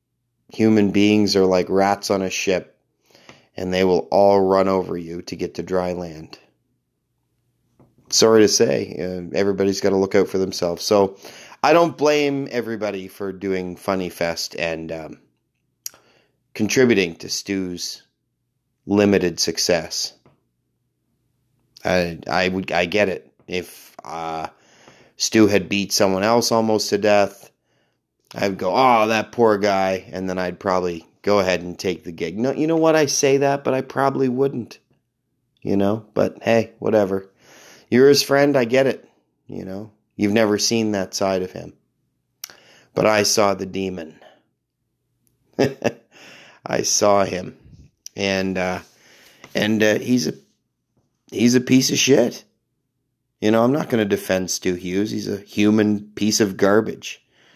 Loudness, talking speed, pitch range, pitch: -19 LUFS, 150 wpm, 95-115 Hz, 100 Hz